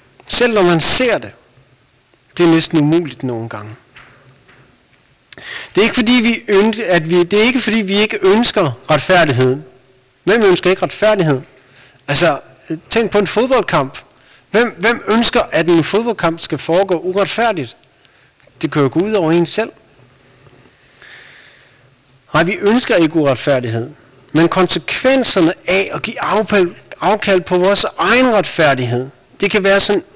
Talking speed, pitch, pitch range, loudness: 145 wpm, 175 Hz, 135-210 Hz, -13 LUFS